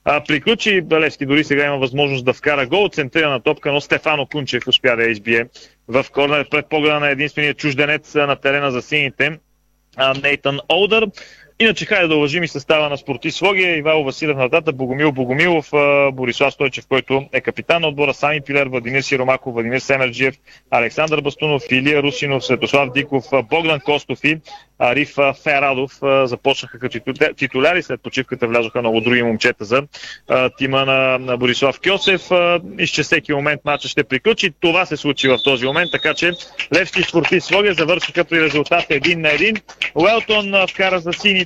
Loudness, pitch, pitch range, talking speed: -16 LUFS, 145 Hz, 135-160 Hz, 160 wpm